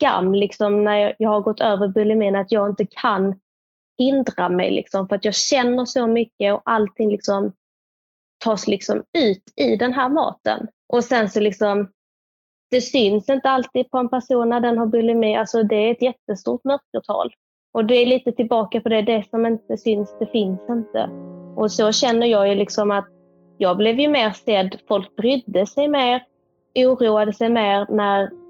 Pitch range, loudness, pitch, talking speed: 205-245 Hz, -20 LUFS, 220 Hz, 180 wpm